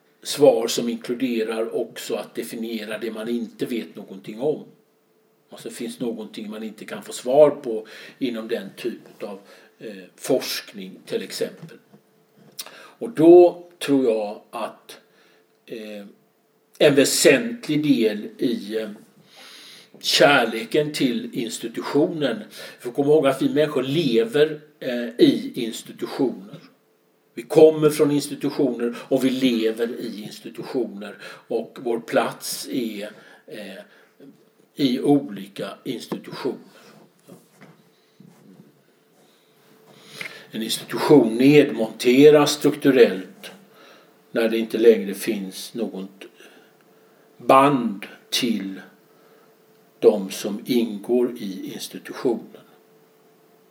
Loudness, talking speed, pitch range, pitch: -21 LUFS, 95 wpm, 110-150 Hz, 125 Hz